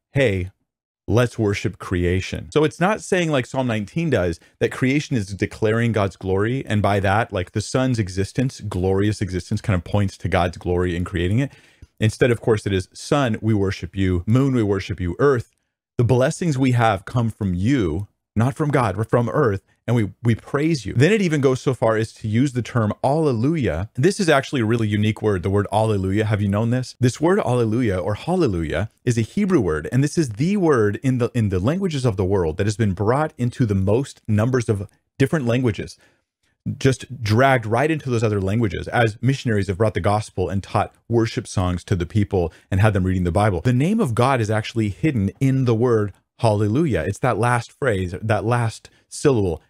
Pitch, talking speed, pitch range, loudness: 110 Hz, 205 wpm, 100-130 Hz, -21 LUFS